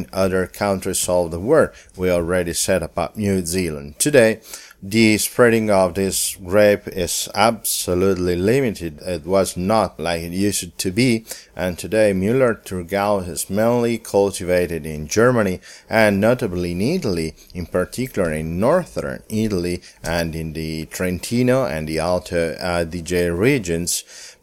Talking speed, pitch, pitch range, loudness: 140 wpm, 90 Hz, 85-100 Hz, -19 LUFS